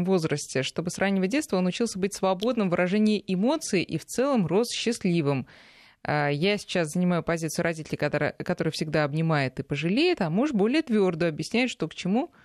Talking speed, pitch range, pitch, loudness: 170 wpm, 160-210 Hz, 180 Hz, -26 LUFS